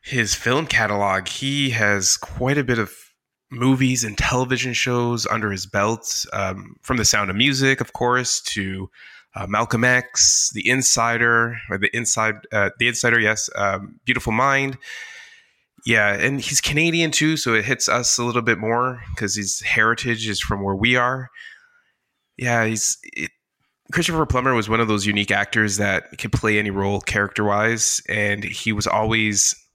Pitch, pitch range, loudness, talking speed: 115 Hz, 105-125 Hz, -19 LUFS, 165 wpm